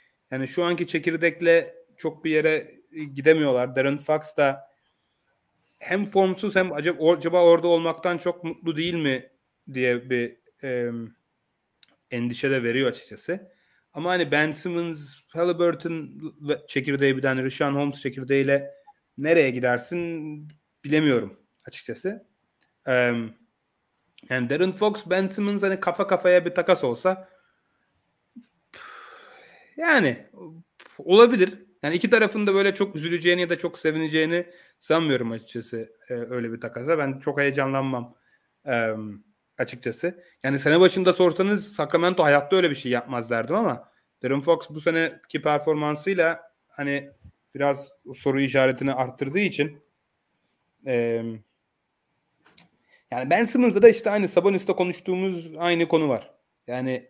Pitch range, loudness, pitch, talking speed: 135-180 Hz, -23 LUFS, 160 Hz, 120 wpm